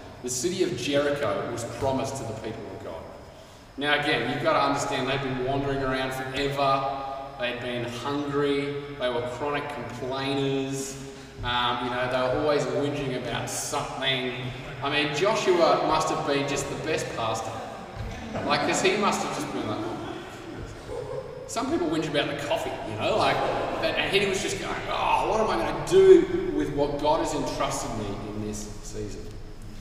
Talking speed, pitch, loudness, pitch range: 175 wpm, 135 Hz, -26 LUFS, 125-145 Hz